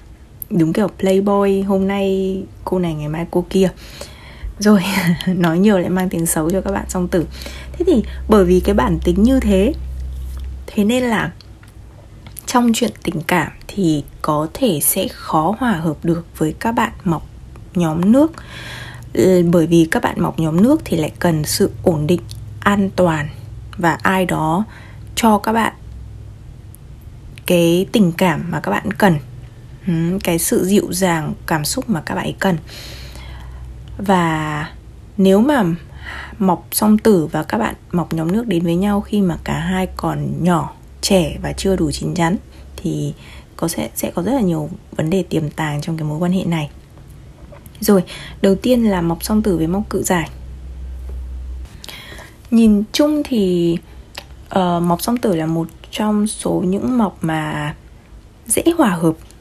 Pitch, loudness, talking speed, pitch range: 180 Hz, -17 LUFS, 165 wpm, 155-200 Hz